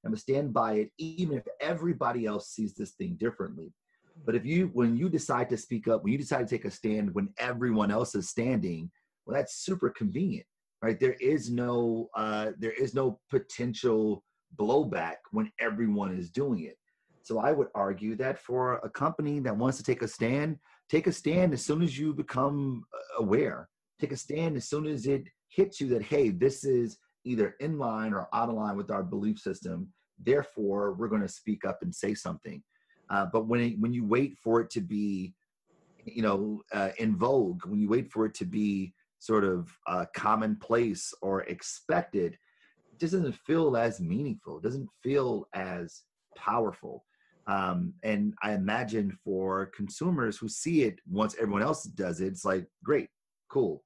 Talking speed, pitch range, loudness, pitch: 185 wpm, 105-155 Hz, -31 LUFS, 120 Hz